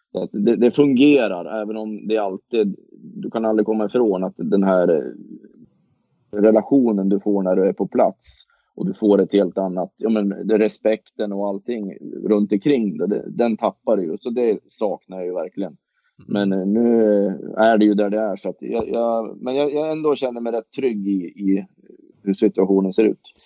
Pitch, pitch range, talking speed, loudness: 105 Hz, 100-115 Hz, 190 wpm, -20 LUFS